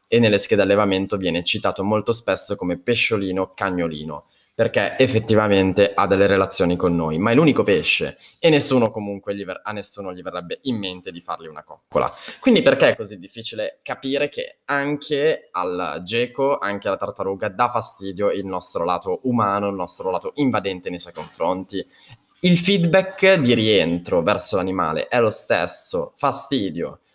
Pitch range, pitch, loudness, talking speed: 95-125 Hz, 100 Hz, -20 LUFS, 160 wpm